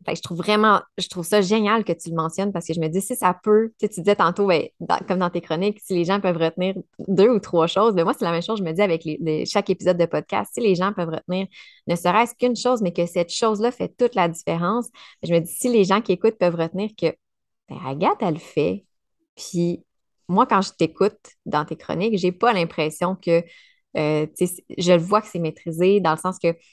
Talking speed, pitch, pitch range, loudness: 265 wpm, 185 Hz, 170-210 Hz, -21 LUFS